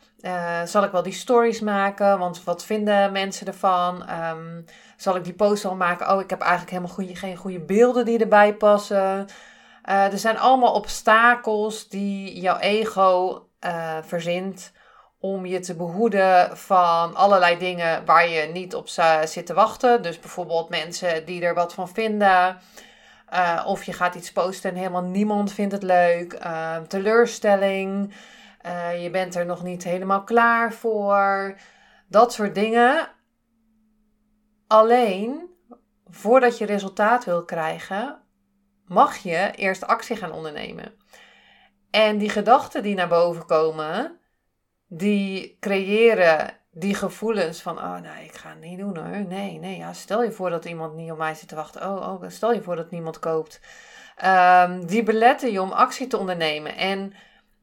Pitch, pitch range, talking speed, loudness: 195 Hz, 175-215 Hz, 160 wpm, -21 LUFS